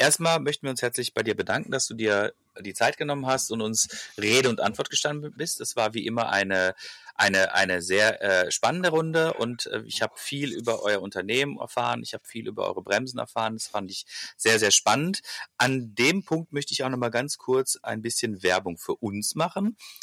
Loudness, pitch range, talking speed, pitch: -25 LUFS, 110-150 Hz, 215 wpm, 125 Hz